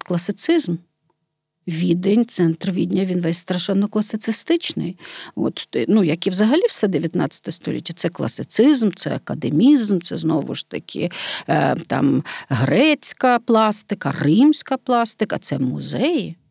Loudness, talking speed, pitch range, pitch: -19 LUFS, 115 wpm, 170-240 Hz, 200 Hz